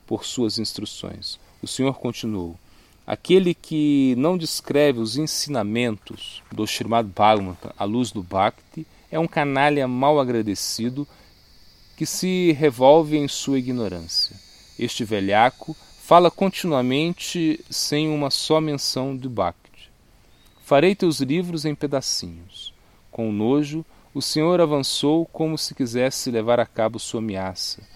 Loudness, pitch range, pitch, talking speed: -22 LUFS, 105-155 Hz, 130 Hz, 125 wpm